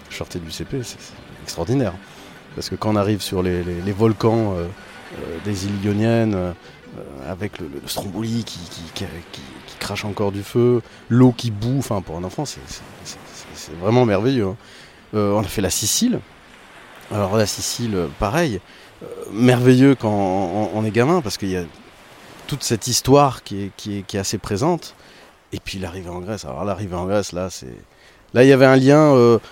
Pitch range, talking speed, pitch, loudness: 95-120 Hz, 200 wpm, 105 Hz, -19 LUFS